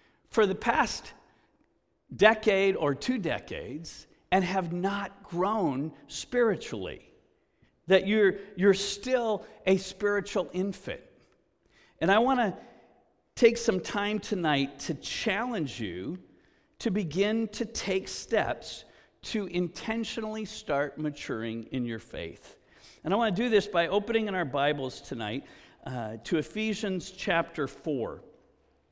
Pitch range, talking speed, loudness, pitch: 165-215 Hz, 120 wpm, -29 LUFS, 195 Hz